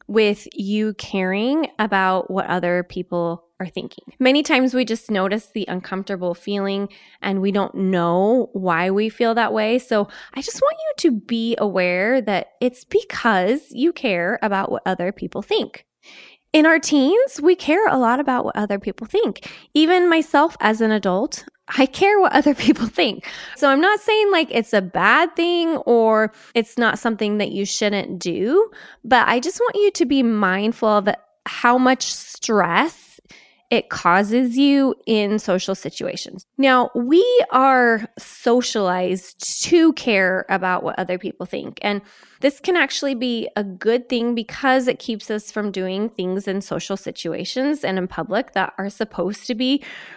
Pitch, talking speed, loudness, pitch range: 225 Hz, 165 wpm, -19 LUFS, 195-275 Hz